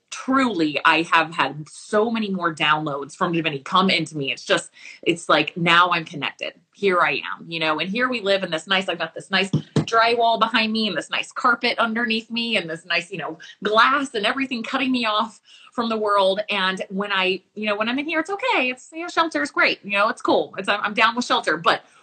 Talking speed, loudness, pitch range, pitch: 235 wpm, -21 LUFS, 170-235 Hz, 200 Hz